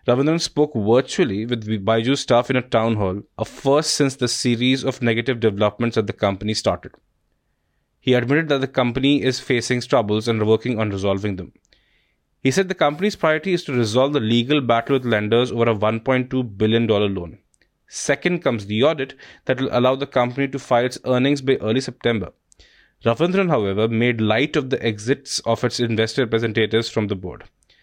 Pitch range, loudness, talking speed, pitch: 110-135 Hz, -20 LUFS, 180 wpm, 120 Hz